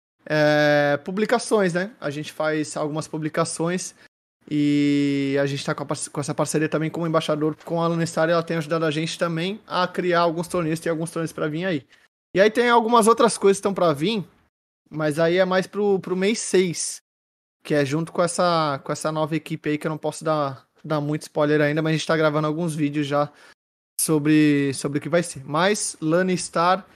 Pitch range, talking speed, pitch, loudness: 150-180 Hz, 205 wpm, 160 Hz, -22 LUFS